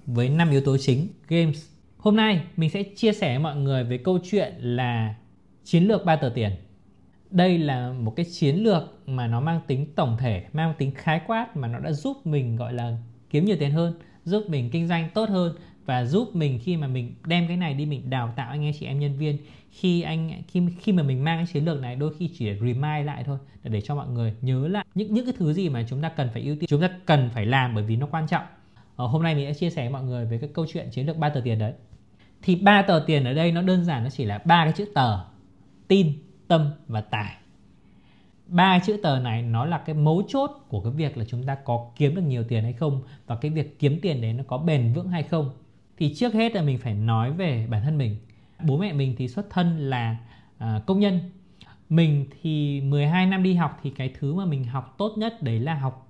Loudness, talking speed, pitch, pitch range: -25 LUFS, 250 wpm, 145 Hz, 125-170 Hz